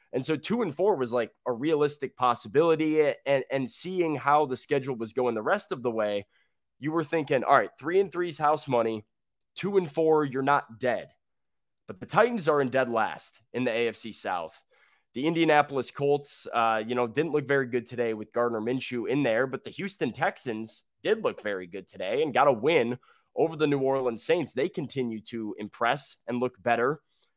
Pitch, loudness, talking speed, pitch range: 135 Hz, -28 LUFS, 200 wpm, 120-155 Hz